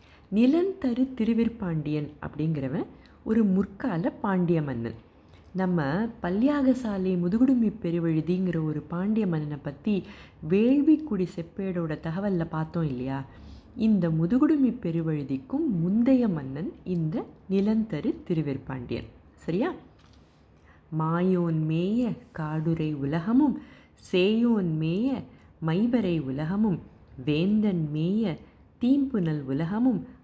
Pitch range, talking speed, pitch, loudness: 155-220 Hz, 80 wpm, 175 Hz, -27 LUFS